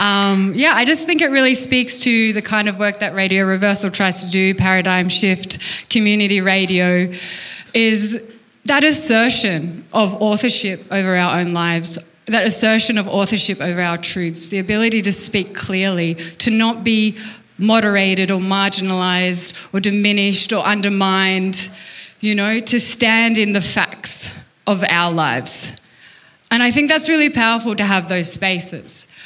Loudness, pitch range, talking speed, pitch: -15 LUFS, 185-225 Hz, 150 wpm, 200 Hz